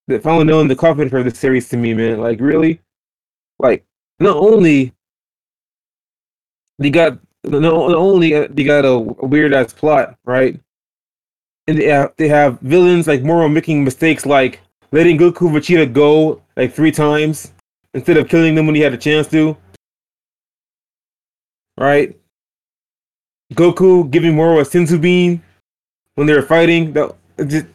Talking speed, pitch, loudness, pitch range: 150 wpm, 150 Hz, -13 LUFS, 140-165 Hz